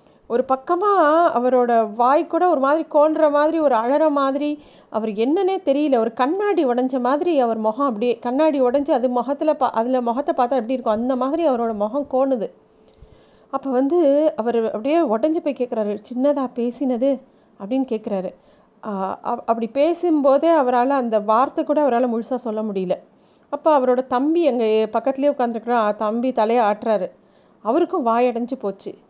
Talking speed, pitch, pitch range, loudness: 145 wpm, 255 Hz, 230-295 Hz, -20 LUFS